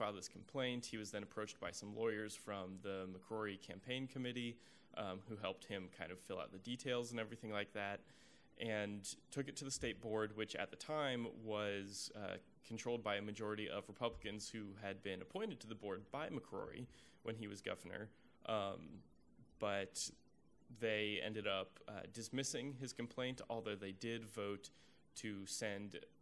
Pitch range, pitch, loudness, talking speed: 100-120 Hz, 105 Hz, -46 LUFS, 175 wpm